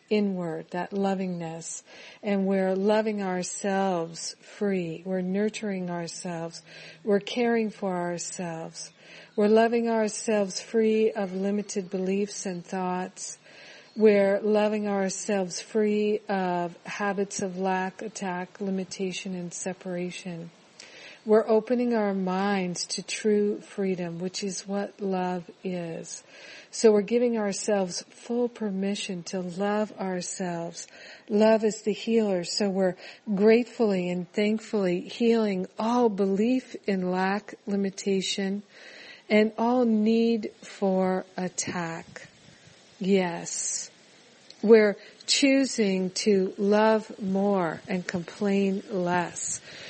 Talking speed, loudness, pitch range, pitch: 105 wpm, -27 LUFS, 185-215 Hz, 200 Hz